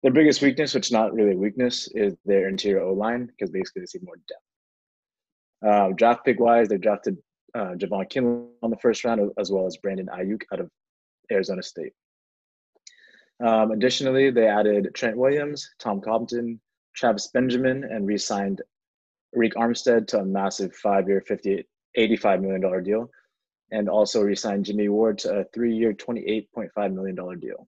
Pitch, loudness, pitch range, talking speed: 110 Hz, -24 LUFS, 100-125 Hz, 160 wpm